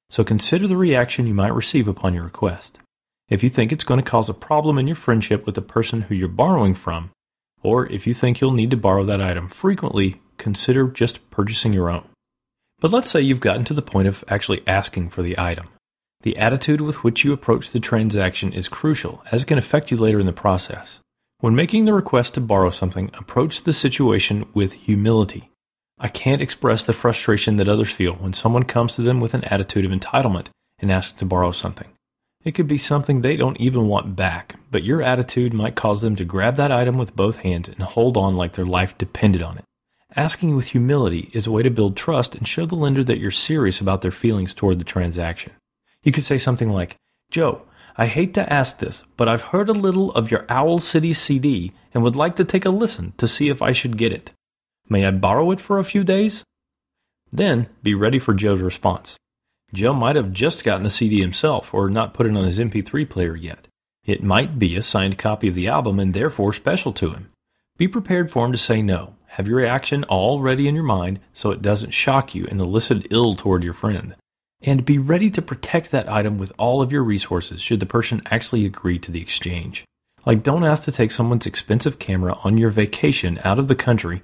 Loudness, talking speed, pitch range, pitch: -20 LUFS, 220 wpm, 95-135 Hz, 115 Hz